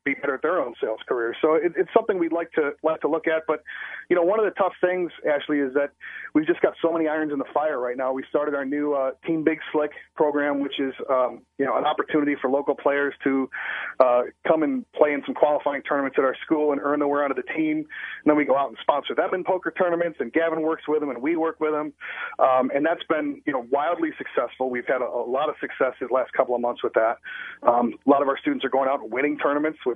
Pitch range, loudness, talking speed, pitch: 140-165 Hz, -24 LUFS, 270 wpm, 150 Hz